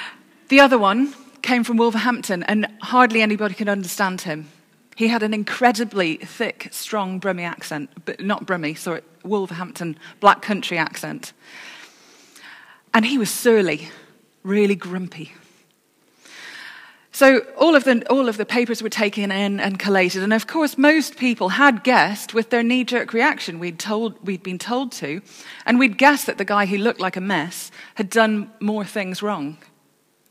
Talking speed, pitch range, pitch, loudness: 160 wpm, 185-235 Hz, 210 Hz, -19 LUFS